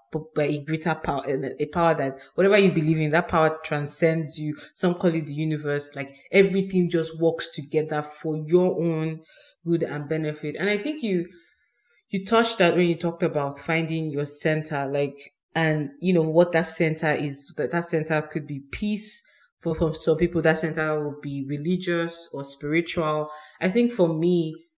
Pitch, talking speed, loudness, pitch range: 160 Hz, 180 wpm, -24 LUFS, 150-175 Hz